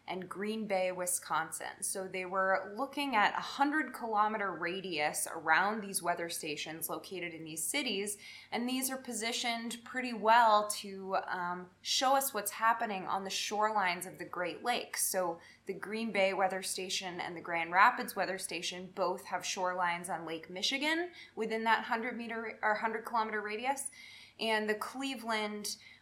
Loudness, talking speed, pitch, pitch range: -34 LUFS, 160 wpm, 205 Hz, 180-230 Hz